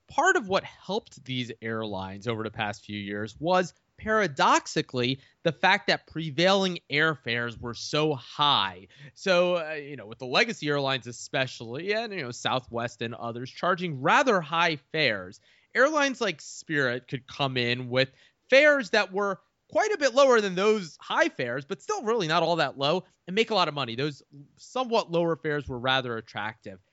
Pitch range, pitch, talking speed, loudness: 120-190 Hz, 150 Hz, 175 wpm, -26 LUFS